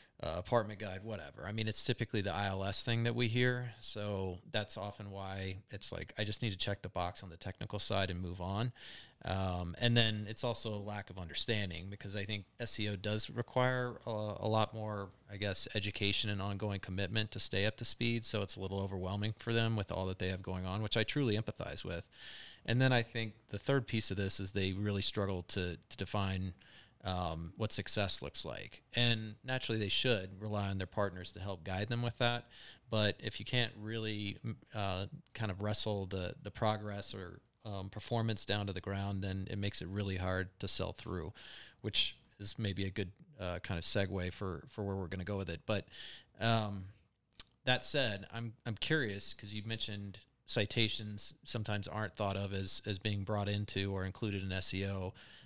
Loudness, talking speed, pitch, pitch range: -37 LUFS, 205 wpm, 105 Hz, 95-115 Hz